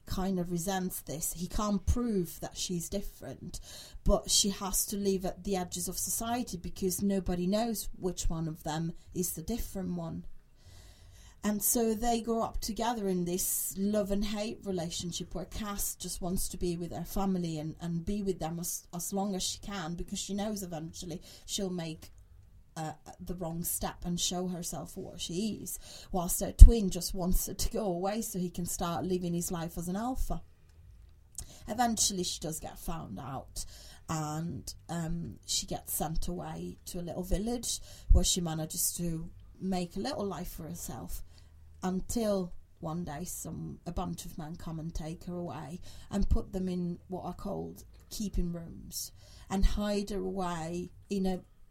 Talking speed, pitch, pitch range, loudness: 175 wpm, 180 Hz, 160-195 Hz, -34 LUFS